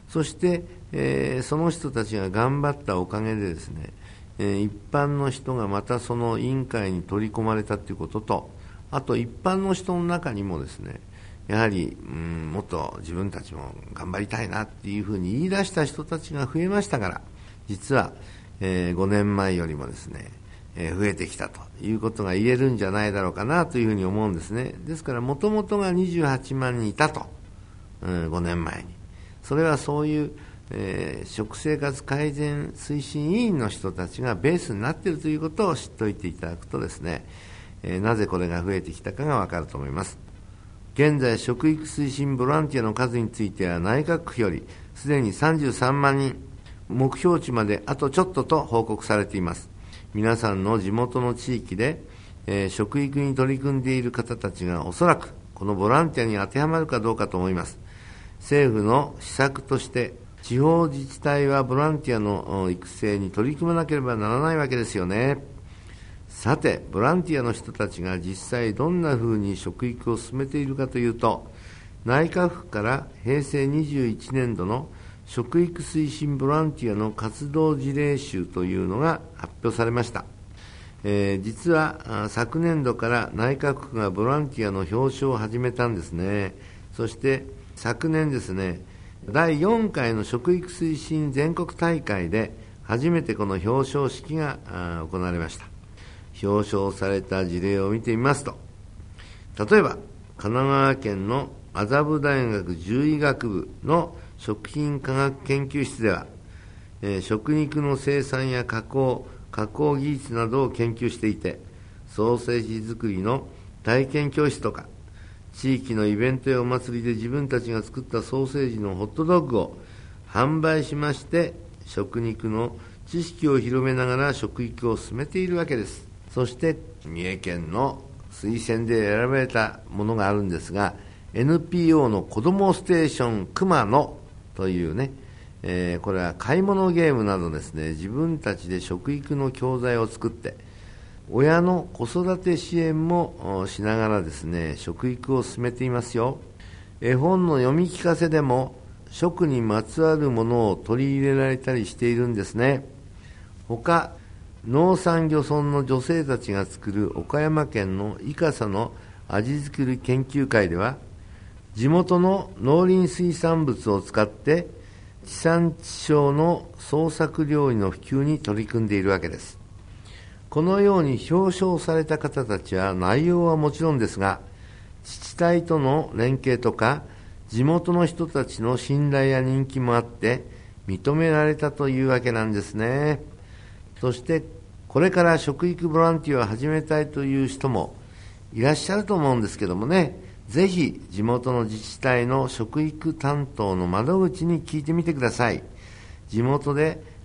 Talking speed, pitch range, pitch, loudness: 305 characters per minute, 100-145 Hz, 115 Hz, -24 LUFS